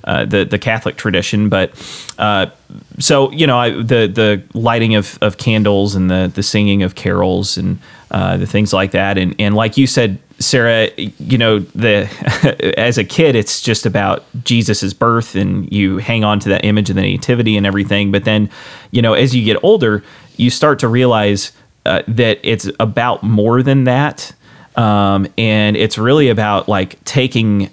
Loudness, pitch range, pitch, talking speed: -13 LUFS, 100-120 Hz, 105 Hz, 180 wpm